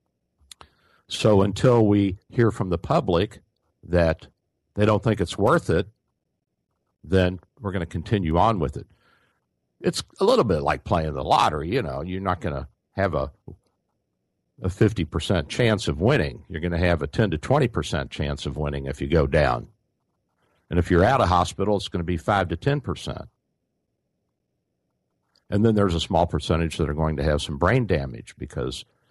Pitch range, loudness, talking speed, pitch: 75-100 Hz, -23 LUFS, 175 wpm, 85 Hz